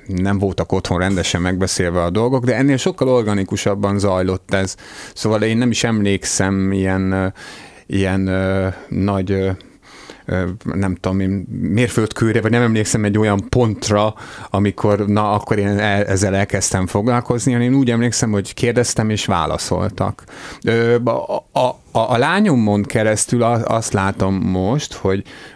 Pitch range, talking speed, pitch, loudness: 95-115 Hz, 140 wpm, 105 Hz, -17 LUFS